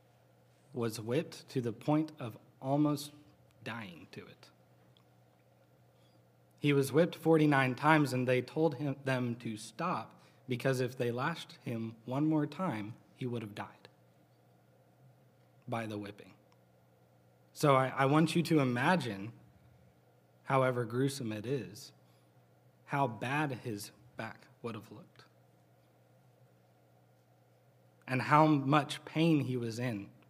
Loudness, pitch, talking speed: -33 LUFS, 120 Hz, 125 wpm